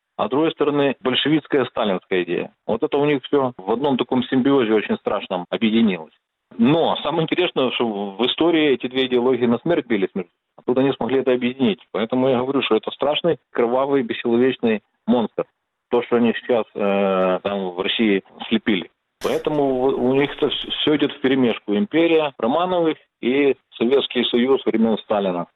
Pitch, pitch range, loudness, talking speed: 130 Hz, 115-140 Hz, -20 LUFS, 160 wpm